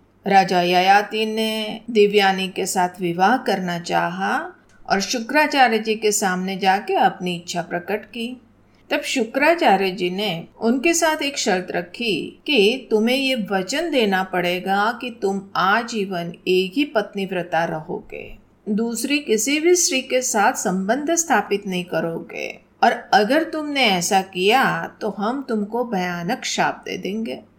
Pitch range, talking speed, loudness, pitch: 185-255 Hz, 140 wpm, -20 LUFS, 210 Hz